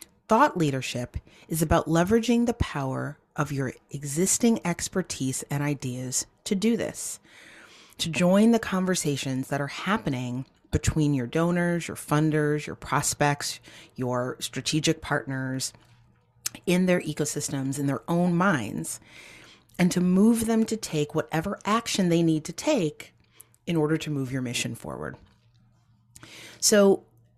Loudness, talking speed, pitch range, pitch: -26 LUFS, 130 wpm, 130-180 Hz, 150 Hz